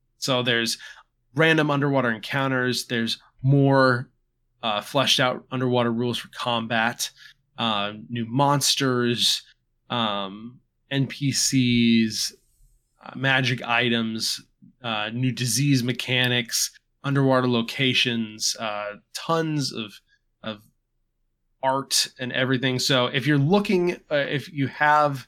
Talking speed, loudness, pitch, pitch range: 100 wpm, -23 LUFS, 125 Hz, 115-135 Hz